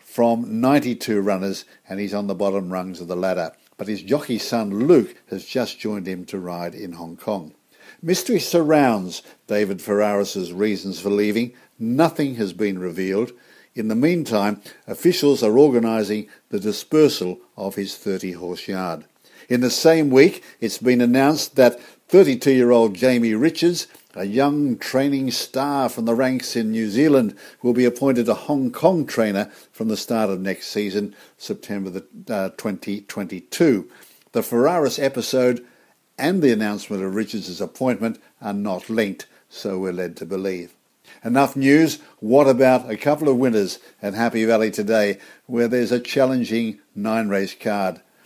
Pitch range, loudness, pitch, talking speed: 100-130 Hz, -20 LUFS, 110 Hz, 155 wpm